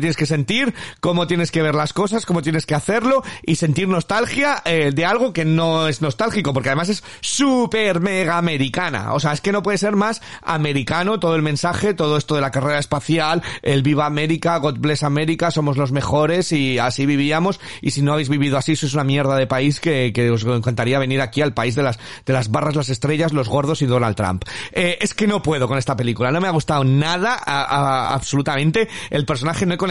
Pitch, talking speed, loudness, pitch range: 150 Hz, 225 wpm, -19 LUFS, 140-175 Hz